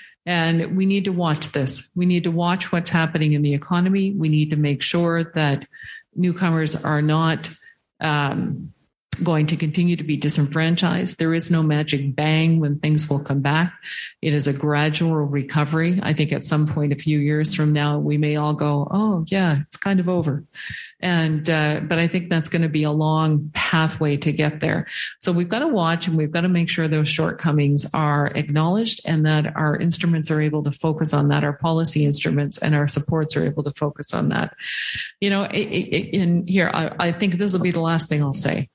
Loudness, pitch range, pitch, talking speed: -20 LUFS, 150-175 Hz, 160 Hz, 210 wpm